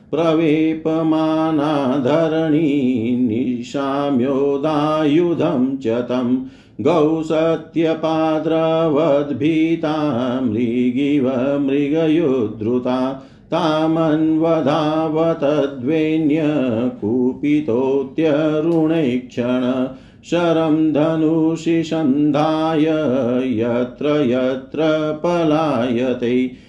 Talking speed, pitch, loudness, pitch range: 35 wpm, 150 Hz, -18 LUFS, 130-160 Hz